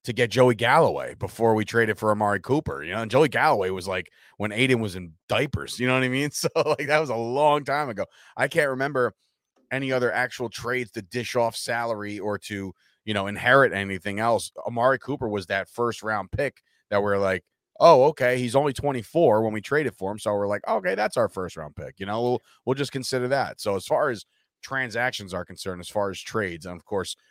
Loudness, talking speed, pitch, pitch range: -24 LUFS, 230 wpm, 115 Hz, 100-130 Hz